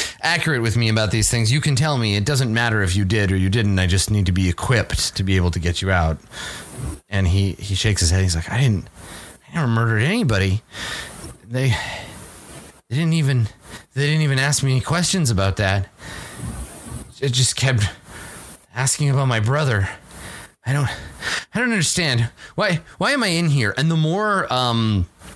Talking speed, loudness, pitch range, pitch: 190 wpm, -20 LUFS, 95-140 Hz, 115 Hz